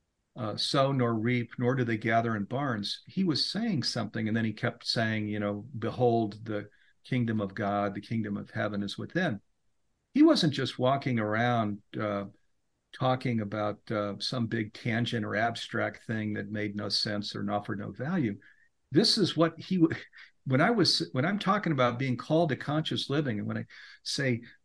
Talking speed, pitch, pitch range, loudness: 185 wpm, 115 Hz, 105-135 Hz, -30 LUFS